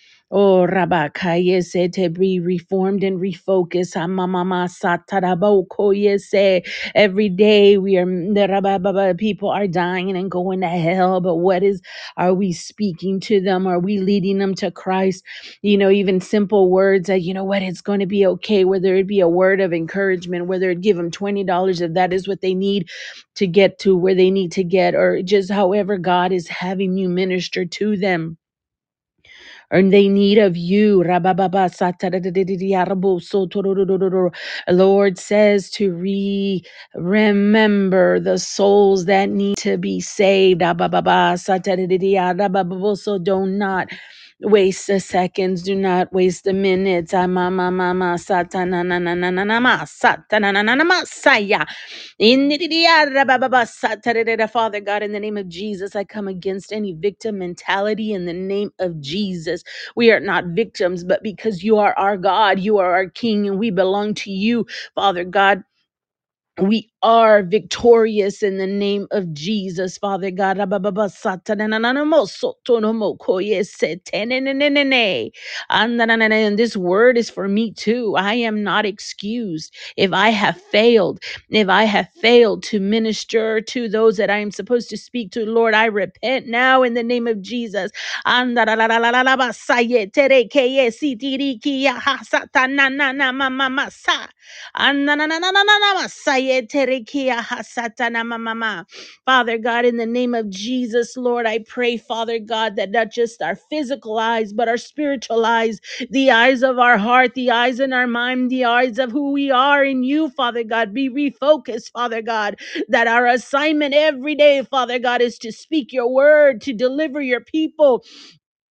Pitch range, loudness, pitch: 190-235 Hz, -17 LUFS, 205 Hz